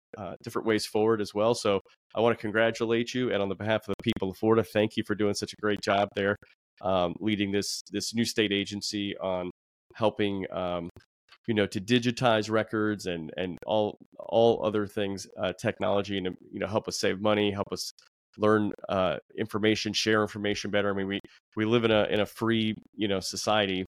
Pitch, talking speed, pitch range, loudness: 105 Hz, 205 wpm, 100-110 Hz, -28 LUFS